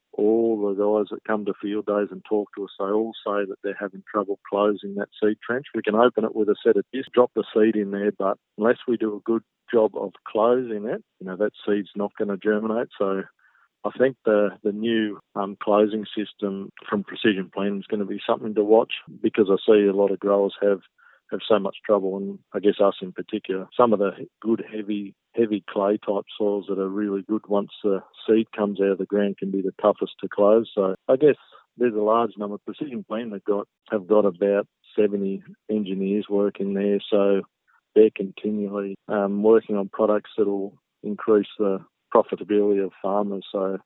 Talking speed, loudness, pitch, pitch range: 210 wpm, -24 LUFS, 105 Hz, 100-110 Hz